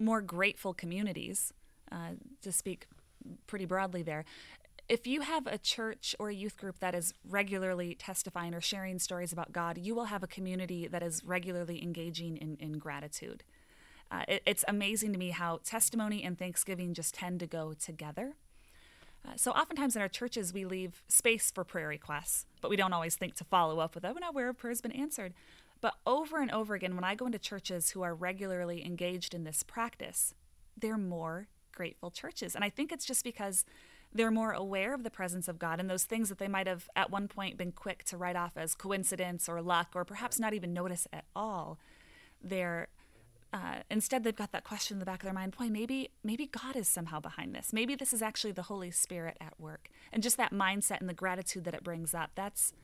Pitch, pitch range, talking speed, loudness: 190 Hz, 175-220 Hz, 210 wpm, -35 LUFS